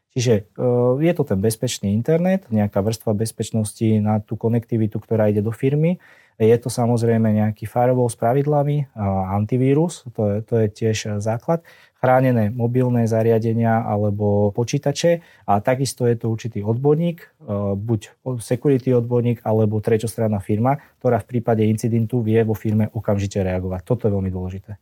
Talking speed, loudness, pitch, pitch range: 145 wpm, -20 LUFS, 115 Hz, 110-125 Hz